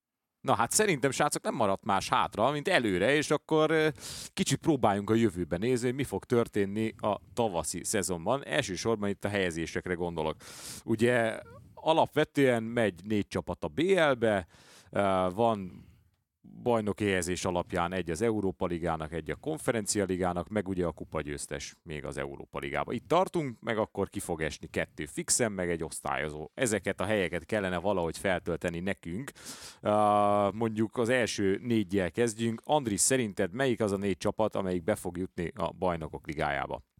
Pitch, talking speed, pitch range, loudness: 100 Hz, 155 wpm, 90-115 Hz, -30 LUFS